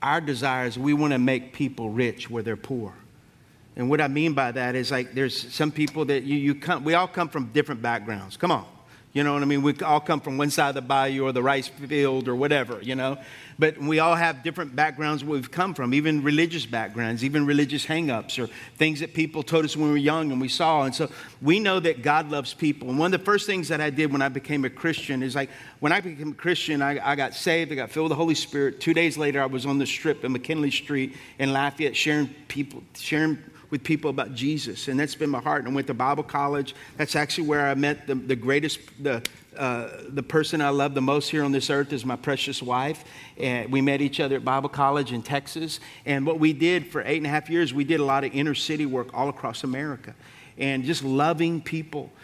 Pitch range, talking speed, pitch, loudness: 135-155 Hz, 250 wpm, 145 Hz, -25 LUFS